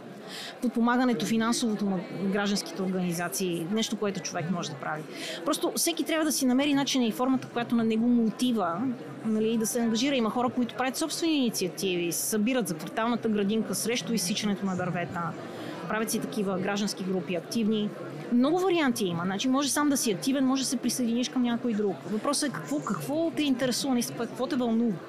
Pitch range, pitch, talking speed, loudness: 195-255 Hz, 230 Hz, 180 wpm, -28 LUFS